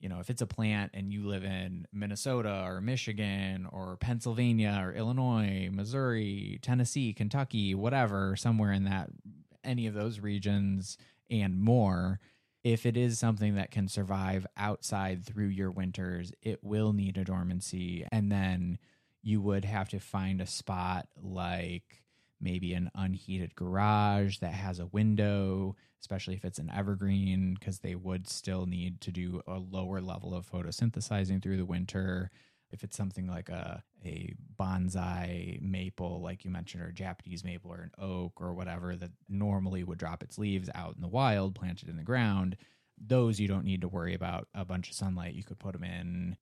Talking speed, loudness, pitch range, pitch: 170 wpm, -34 LUFS, 90-105 Hz, 95 Hz